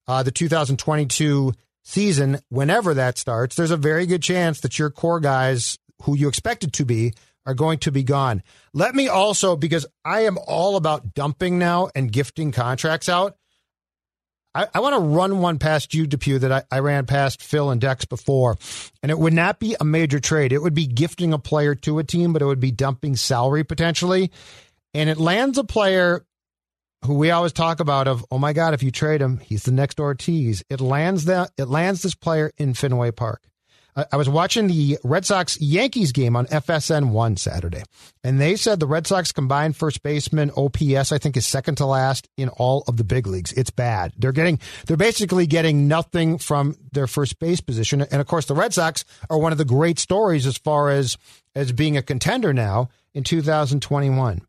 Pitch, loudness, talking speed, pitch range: 145 Hz, -21 LUFS, 205 wpm, 130-165 Hz